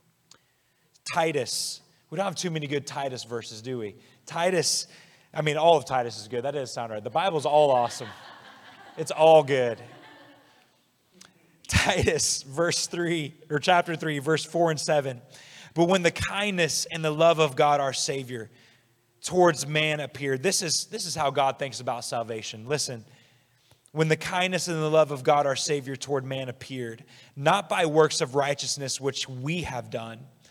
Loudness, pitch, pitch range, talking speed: -25 LUFS, 145 Hz, 130-165 Hz, 170 wpm